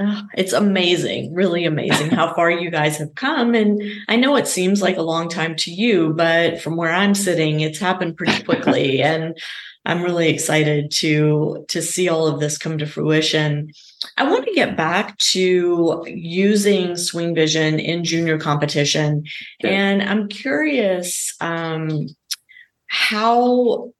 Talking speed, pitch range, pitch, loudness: 150 wpm, 155-200 Hz, 170 Hz, -18 LUFS